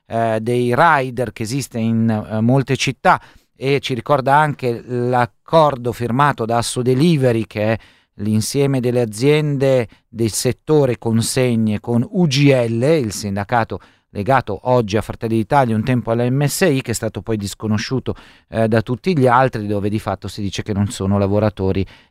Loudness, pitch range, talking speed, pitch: -18 LUFS, 110-130 Hz, 155 wpm, 120 Hz